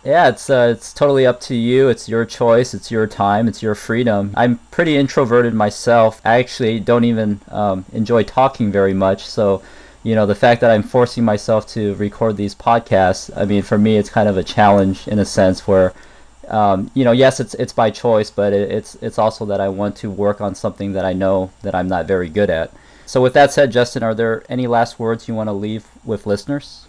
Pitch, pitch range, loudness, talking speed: 110 Hz, 100-120 Hz, -16 LUFS, 225 wpm